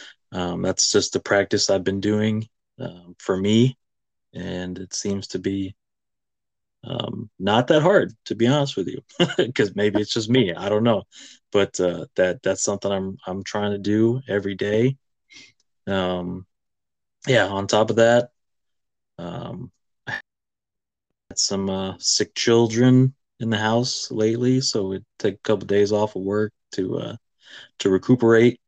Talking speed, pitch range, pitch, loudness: 155 wpm, 95-115 Hz, 100 Hz, -22 LUFS